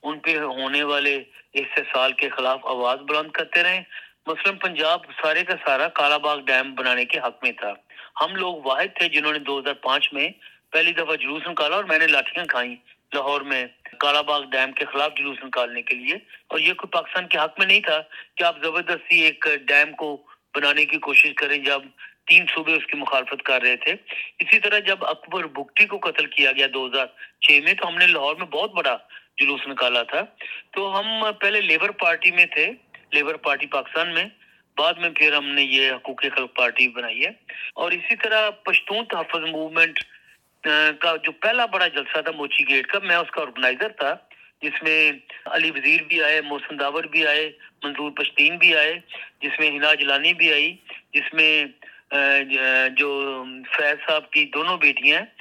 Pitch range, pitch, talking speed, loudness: 140-170 Hz, 150 Hz, 185 wpm, -20 LUFS